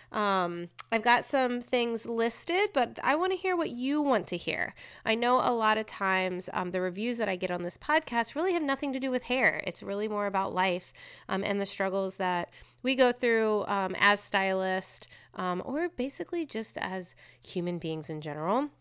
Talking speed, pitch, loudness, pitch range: 200 wpm, 215 Hz, -30 LUFS, 185-255 Hz